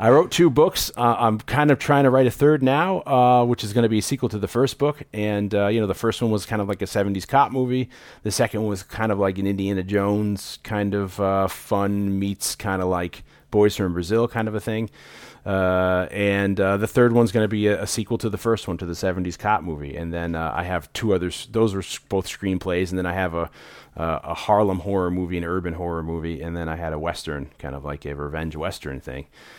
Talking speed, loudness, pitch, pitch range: 255 wpm, -22 LUFS, 100 Hz, 90-115 Hz